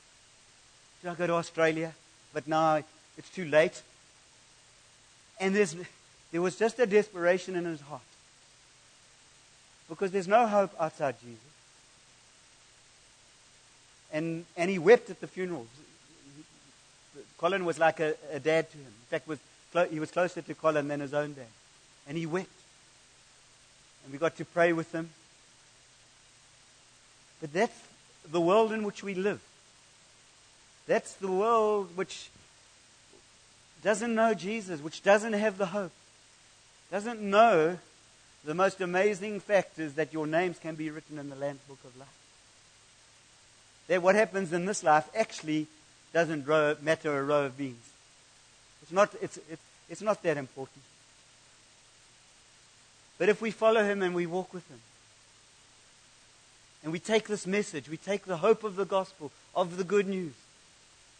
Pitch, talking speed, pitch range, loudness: 160 Hz, 145 wpm, 140-190 Hz, -30 LUFS